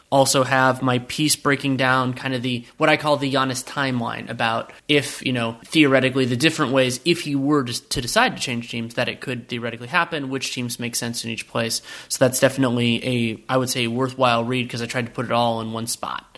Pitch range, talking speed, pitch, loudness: 120-135 Hz, 230 wpm, 130 Hz, -21 LUFS